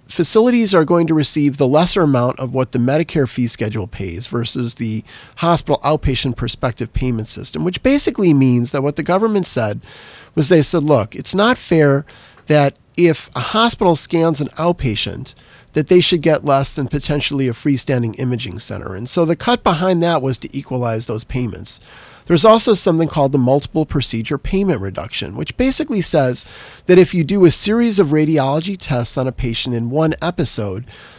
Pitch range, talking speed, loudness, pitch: 125-170 Hz, 180 wpm, -16 LUFS, 145 Hz